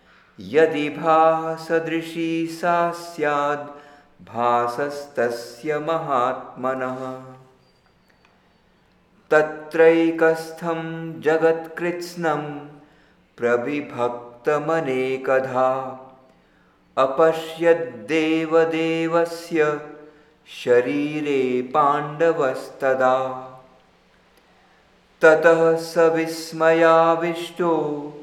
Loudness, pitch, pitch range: -21 LUFS, 155 Hz, 130-165 Hz